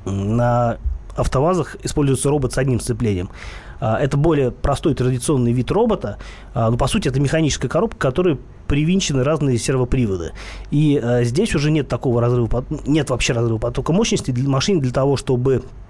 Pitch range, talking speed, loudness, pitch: 120-145 Hz, 150 wpm, -19 LUFS, 130 Hz